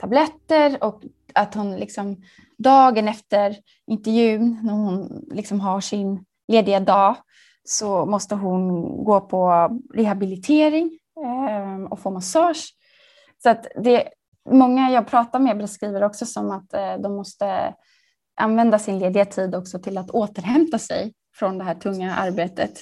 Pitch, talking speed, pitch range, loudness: 210 Hz, 135 wpm, 195-240 Hz, -20 LUFS